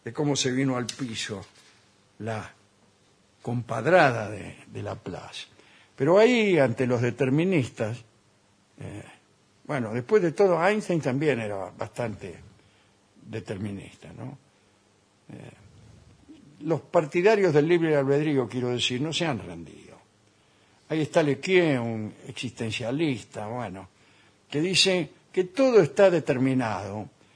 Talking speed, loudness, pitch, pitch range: 110 wpm, -25 LUFS, 125 Hz, 105-150 Hz